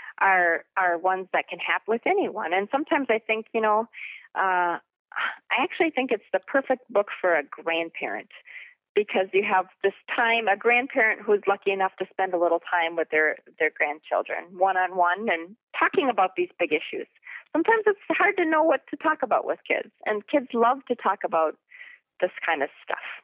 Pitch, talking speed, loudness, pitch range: 215 Hz, 190 wpm, -25 LUFS, 185-300 Hz